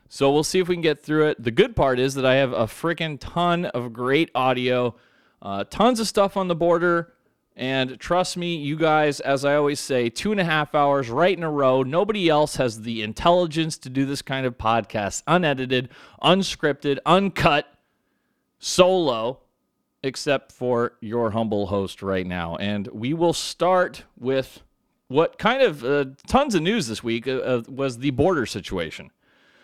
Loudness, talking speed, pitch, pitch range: -22 LUFS, 180 wpm, 140 Hz, 125-170 Hz